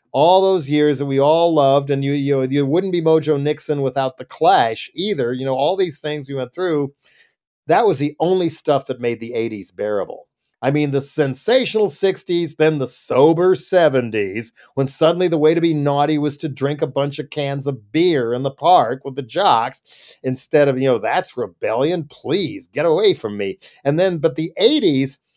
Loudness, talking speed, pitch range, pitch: -18 LUFS, 200 wpm, 135-165 Hz, 145 Hz